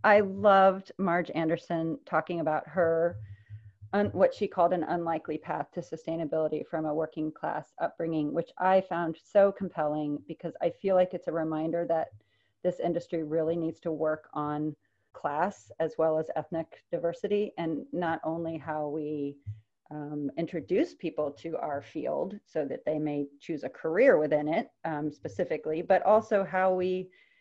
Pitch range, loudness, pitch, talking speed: 155-175 Hz, -30 LUFS, 165 Hz, 160 wpm